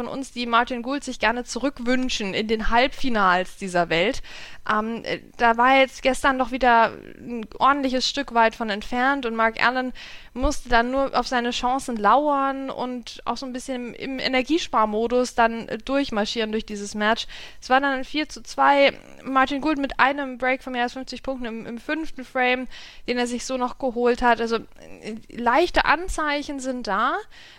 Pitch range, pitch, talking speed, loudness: 230-265 Hz, 250 Hz, 175 wpm, -23 LUFS